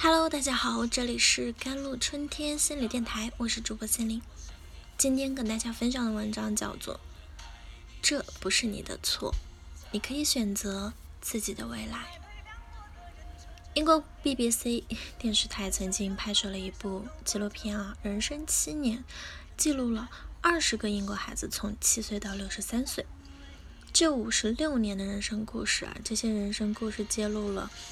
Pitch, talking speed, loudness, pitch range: 220 Hz, 245 characters per minute, -30 LUFS, 195-240 Hz